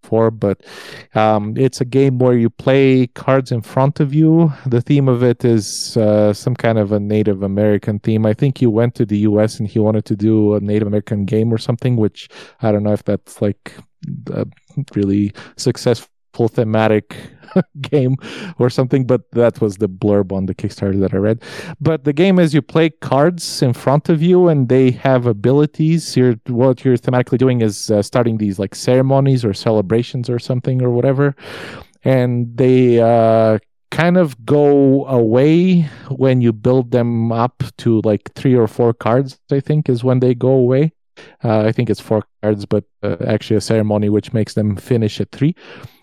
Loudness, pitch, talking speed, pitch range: -16 LUFS, 120 Hz, 190 wpm, 110-135 Hz